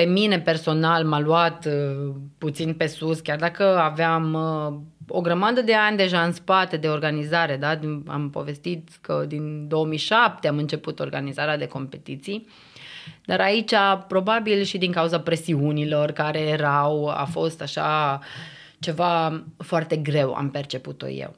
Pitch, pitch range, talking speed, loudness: 160 Hz, 150-170 Hz, 140 wpm, -23 LUFS